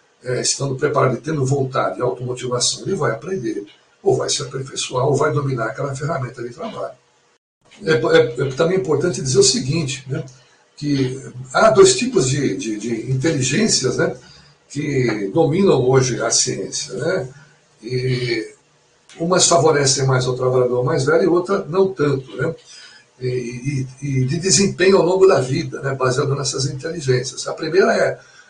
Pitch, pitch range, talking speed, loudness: 140 Hz, 130-165 Hz, 155 wpm, -18 LUFS